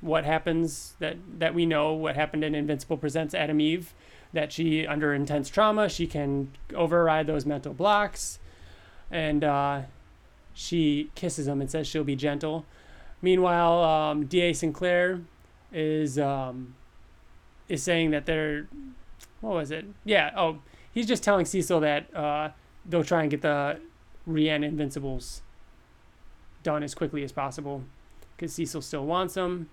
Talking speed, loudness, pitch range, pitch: 145 wpm, -27 LUFS, 145-170 Hz, 155 Hz